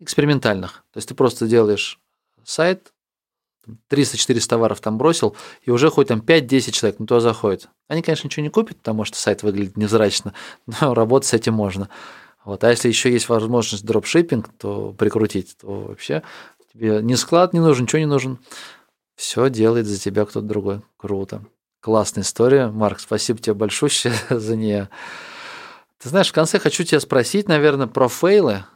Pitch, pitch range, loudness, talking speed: 115 Hz, 105-145 Hz, -19 LUFS, 165 wpm